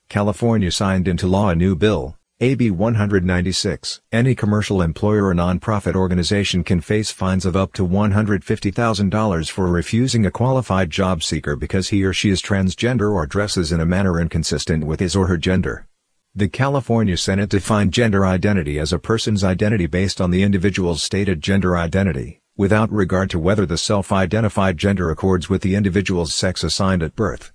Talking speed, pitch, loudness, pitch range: 170 wpm, 95 Hz, -19 LUFS, 90-105 Hz